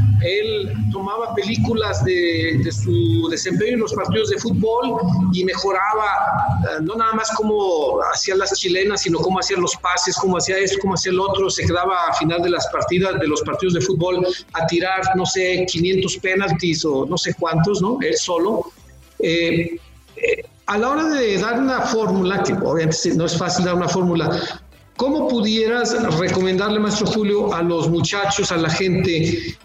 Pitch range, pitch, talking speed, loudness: 170-210 Hz, 185 Hz, 175 wpm, -19 LUFS